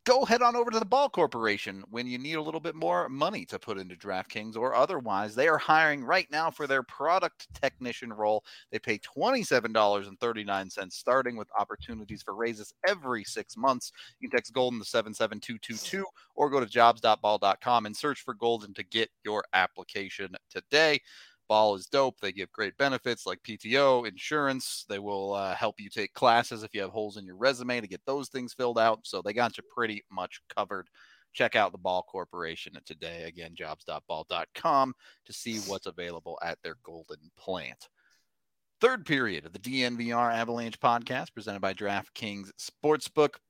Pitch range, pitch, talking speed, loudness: 105-135 Hz, 115 Hz, 185 wpm, -29 LUFS